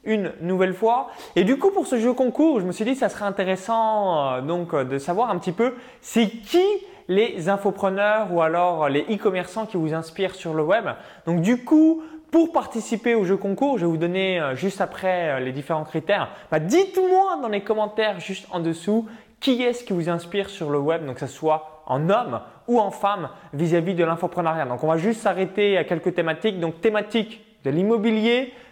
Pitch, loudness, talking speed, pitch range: 200 Hz, -23 LUFS, 205 wpm, 170-230 Hz